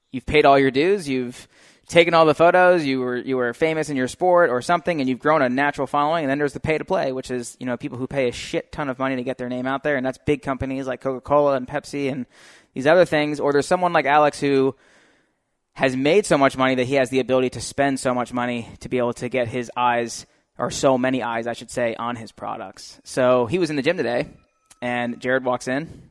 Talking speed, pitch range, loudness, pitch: 255 wpm, 125-145 Hz, -21 LUFS, 135 Hz